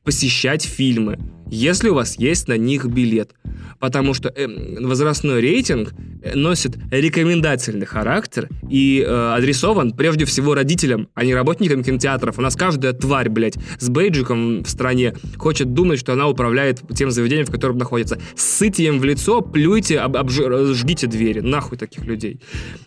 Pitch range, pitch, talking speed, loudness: 120-145 Hz, 130 Hz, 145 wpm, -18 LUFS